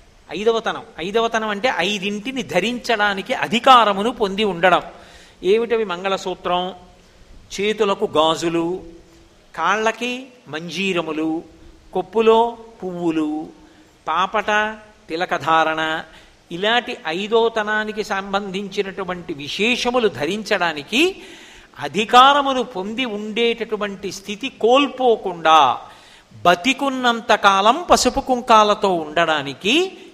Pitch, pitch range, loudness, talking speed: 210 Hz, 180-235 Hz, -18 LUFS, 65 wpm